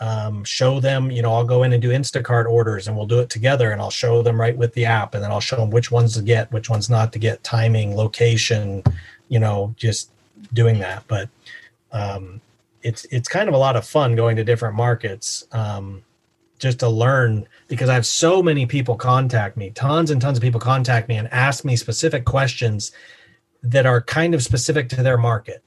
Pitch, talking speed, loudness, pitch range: 120 Hz, 215 wpm, -19 LUFS, 110-130 Hz